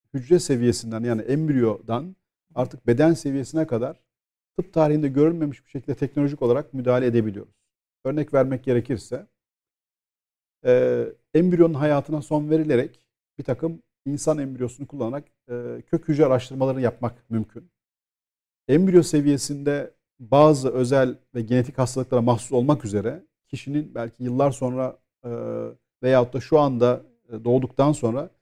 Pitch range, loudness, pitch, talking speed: 120-150 Hz, -23 LUFS, 135 Hz, 120 wpm